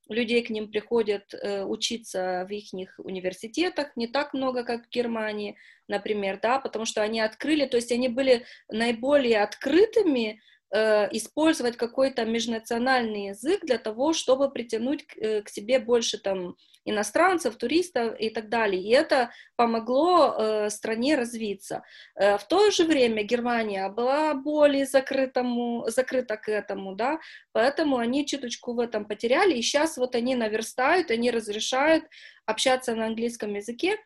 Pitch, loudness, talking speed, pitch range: 240 Hz, -26 LUFS, 135 wpm, 215-270 Hz